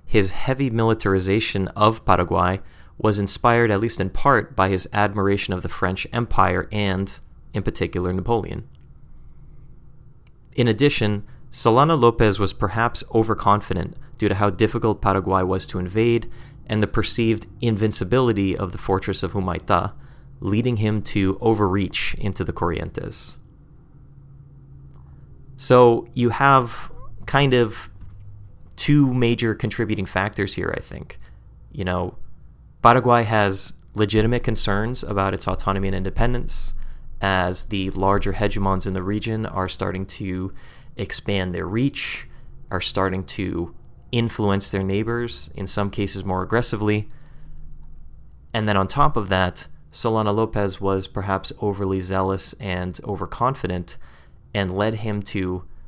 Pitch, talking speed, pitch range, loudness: 105 Hz, 125 wpm, 95-115 Hz, -22 LUFS